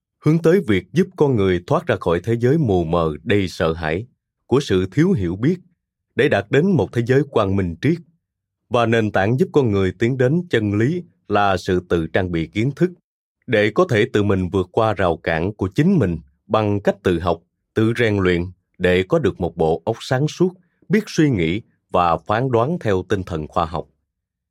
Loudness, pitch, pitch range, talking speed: -19 LUFS, 105 Hz, 90-140 Hz, 210 wpm